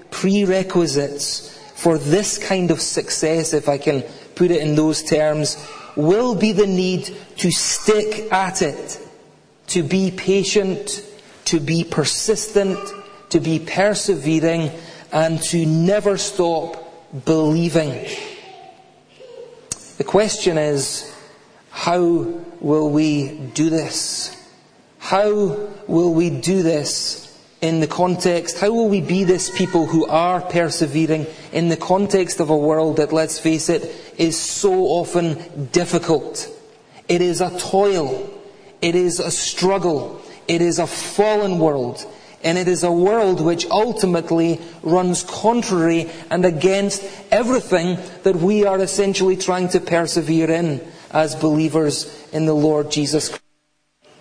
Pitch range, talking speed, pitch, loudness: 160-195 Hz, 125 wpm, 175 Hz, -19 LUFS